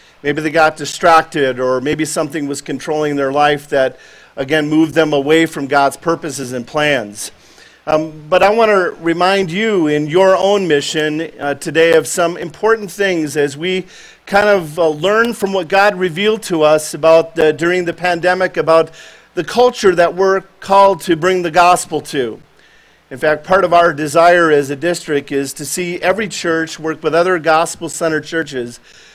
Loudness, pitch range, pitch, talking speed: -14 LUFS, 150-185 Hz, 165 Hz, 175 wpm